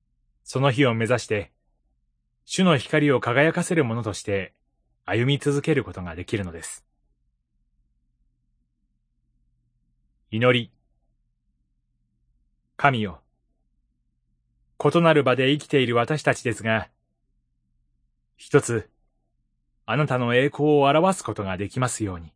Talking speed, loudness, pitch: 205 characters per minute, -22 LUFS, 110 Hz